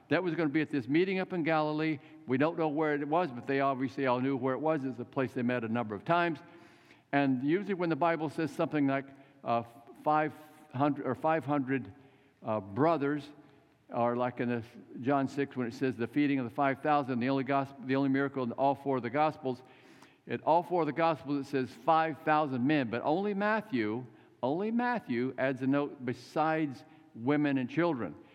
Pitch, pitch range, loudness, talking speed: 140 Hz, 130-155 Hz, -32 LUFS, 210 wpm